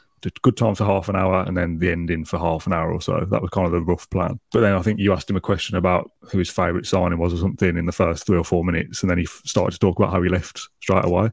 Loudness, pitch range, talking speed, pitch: -21 LUFS, 85-95 Hz, 320 wpm, 90 Hz